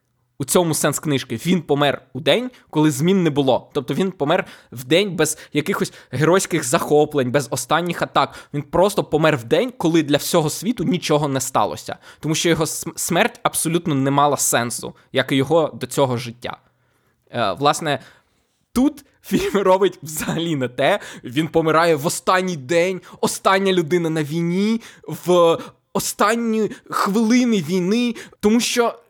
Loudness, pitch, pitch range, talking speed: -19 LUFS, 165 Hz, 145-190 Hz, 155 wpm